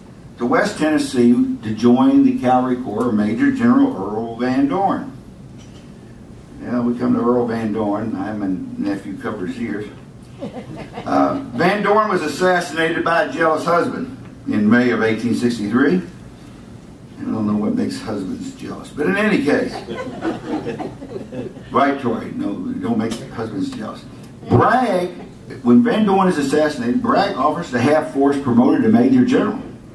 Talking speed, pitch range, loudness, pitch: 145 wpm, 120-195 Hz, -18 LUFS, 140 Hz